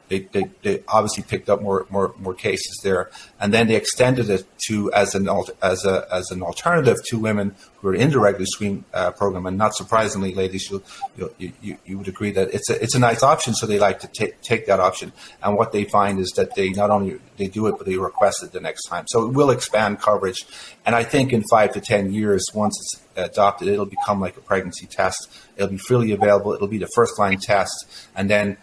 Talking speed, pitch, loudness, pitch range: 235 wpm, 100 Hz, -20 LUFS, 95-110 Hz